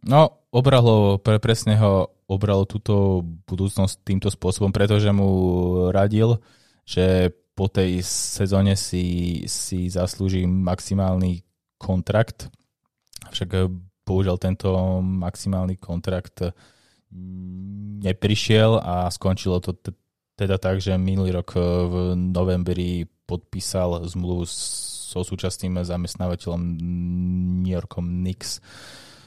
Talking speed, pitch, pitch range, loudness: 95 wpm, 95 Hz, 90-100 Hz, -22 LUFS